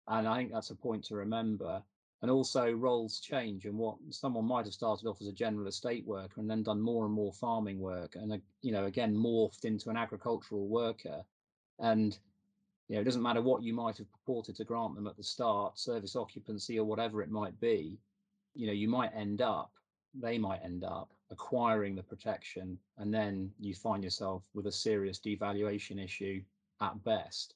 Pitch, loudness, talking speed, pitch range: 105 Hz, -36 LUFS, 195 wpm, 100-115 Hz